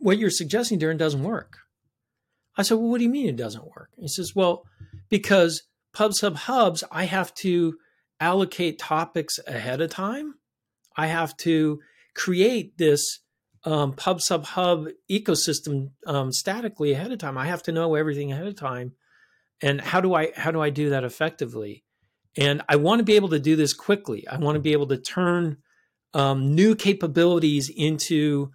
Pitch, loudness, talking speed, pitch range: 160 Hz, -24 LUFS, 180 wpm, 145-185 Hz